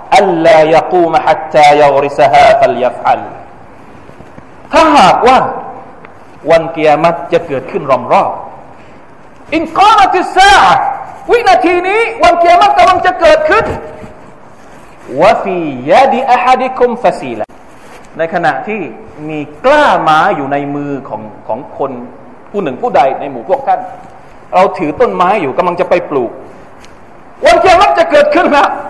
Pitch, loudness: 275 Hz, -9 LUFS